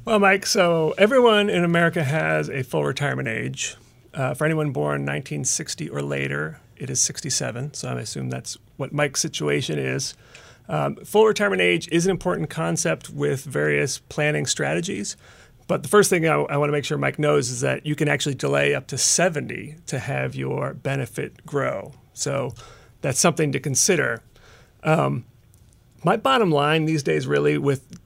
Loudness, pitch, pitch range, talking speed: -22 LUFS, 145 Hz, 100-165 Hz, 170 wpm